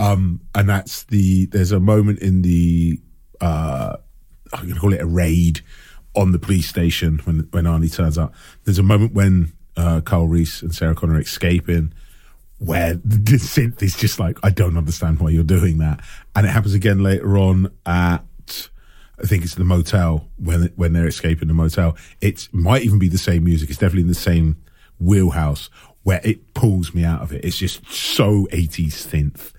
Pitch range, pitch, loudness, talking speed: 80-100 Hz, 85 Hz, -18 LUFS, 195 wpm